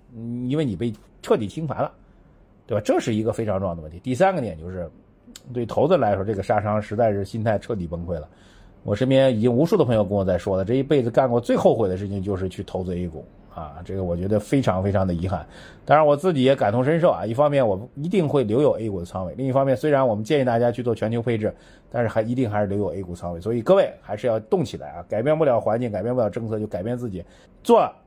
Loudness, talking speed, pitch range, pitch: -22 LUFS, 385 characters per minute, 95-125 Hz, 110 Hz